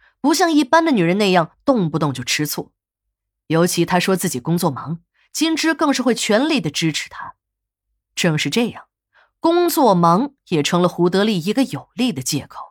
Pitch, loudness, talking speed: 180 Hz, -18 LUFS, 260 characters per minute